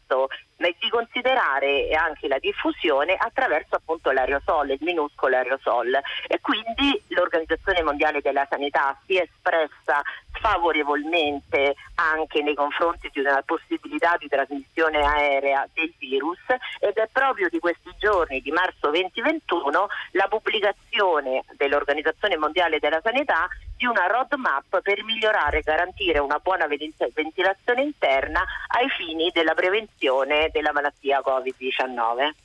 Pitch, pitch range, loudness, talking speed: 160 Hz, 145-200 Hz, -23 LUFS, 120 wpm